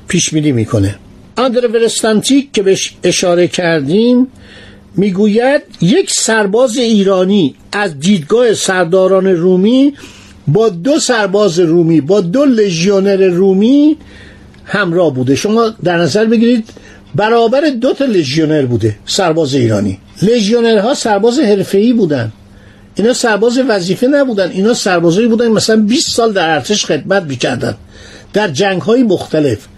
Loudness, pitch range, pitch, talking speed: -11 LUFS, 165-230 Hz, 195 Hz, 120 wpm